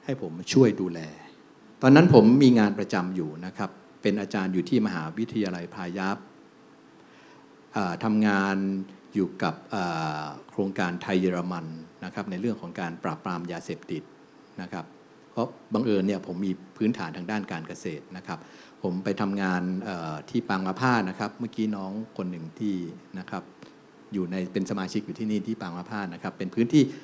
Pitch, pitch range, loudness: 95 Hz, 90-105 Hz, -27 LUFS